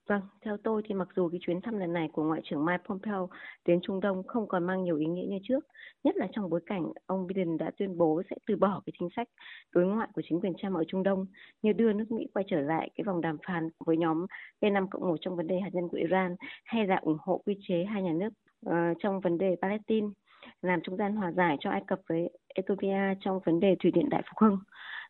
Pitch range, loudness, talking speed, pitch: 175-205 Hz, -31 LUFS, 255 wpm, 190 Hz